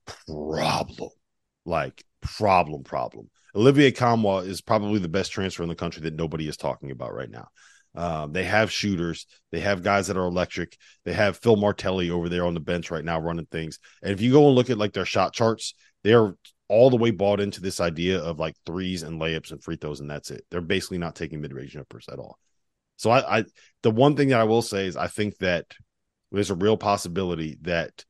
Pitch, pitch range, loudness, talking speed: 95 Hz, 80-105 Hz, -24 LUFS, 220 wpm